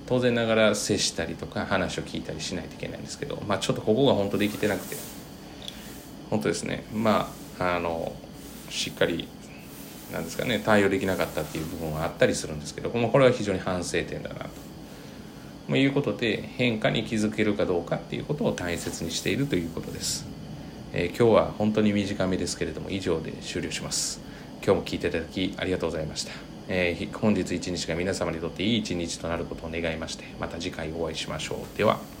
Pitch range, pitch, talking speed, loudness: 85-110 Hz, 100 Hz, 435 characters per minute, -27 LUFS